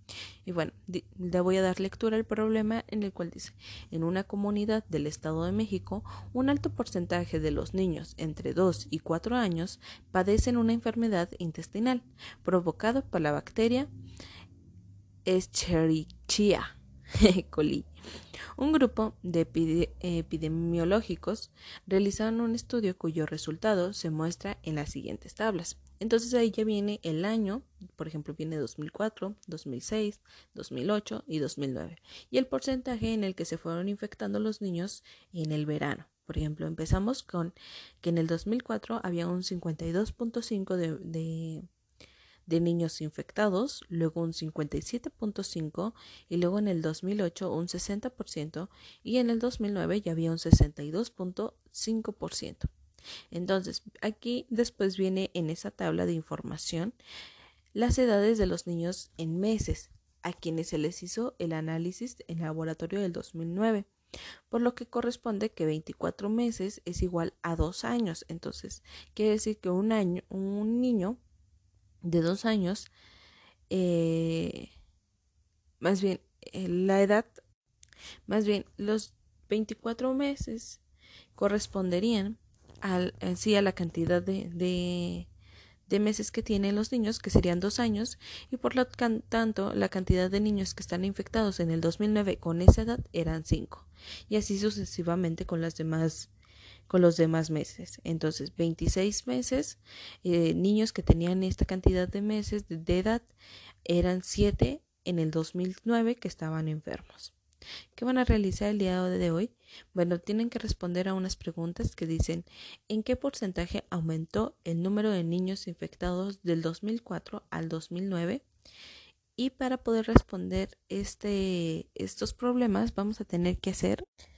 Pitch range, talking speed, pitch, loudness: 165-215 Hz, 140 wpm, 185 Hz, -31 LUFS